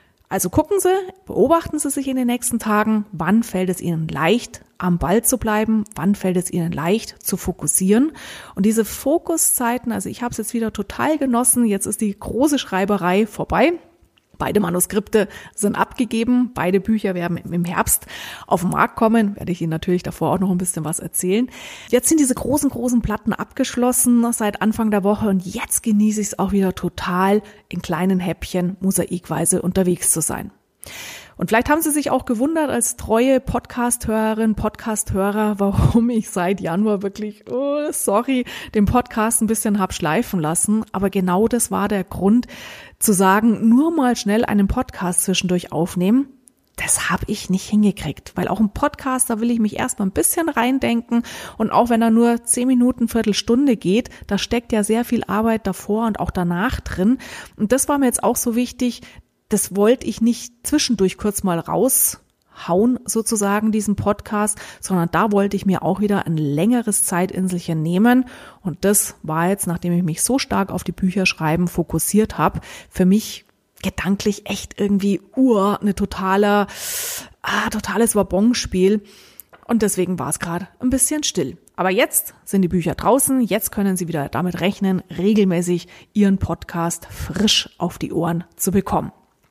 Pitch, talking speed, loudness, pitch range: 210 Hz, 170 wpm, -19 LUFS, 185-235 Hz